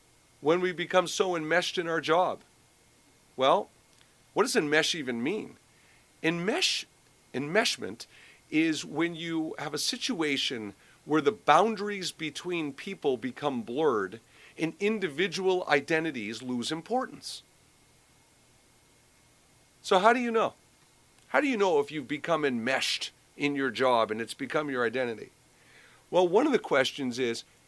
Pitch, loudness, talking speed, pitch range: 160 Hz, -28 LUFS, 130 wpm, 140-190 Hz